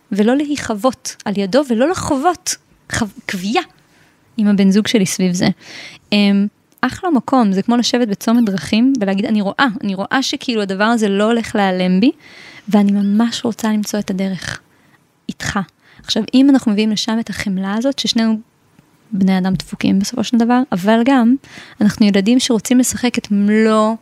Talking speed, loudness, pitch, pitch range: 160 wpm, -16 LUFS, 220 Hz, 200-245 Hz